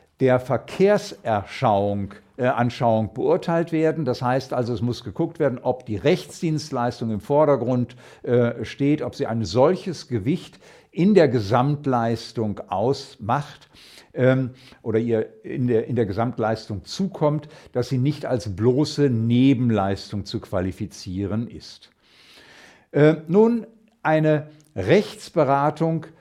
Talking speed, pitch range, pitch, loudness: 115 wpm, 115-150 Hz, 125 Hz, -22 LUFS